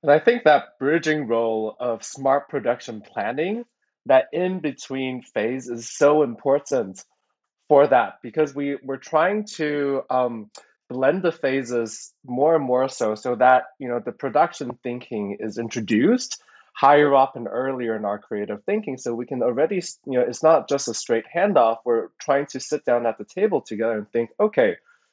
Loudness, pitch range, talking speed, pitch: -22 LUFS, 120-150 Hz, 170 wpm, 135 Hz